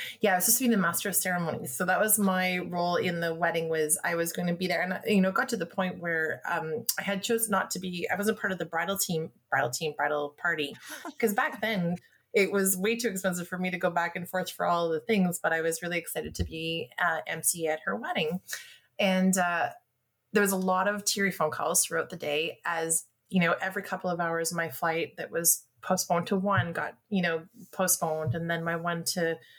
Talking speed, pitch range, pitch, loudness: 245 wpm, 165-195 Hz, 175 Hz, -28 LUFS